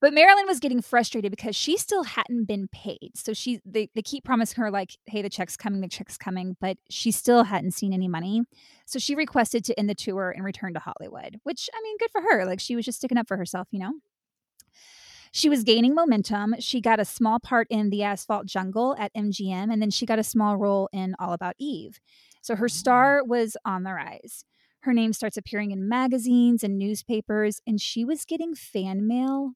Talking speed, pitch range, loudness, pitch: 215 wpm, 200-250 Hz, -25 LUFS, 220 Hz